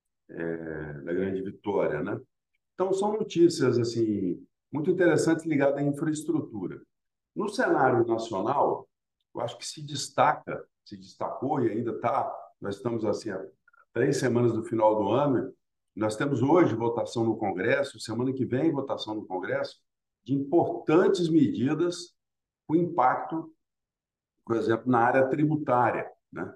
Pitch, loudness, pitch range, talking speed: 125 Hz, -27 LUFS, 110-150 Hz, 135 wpm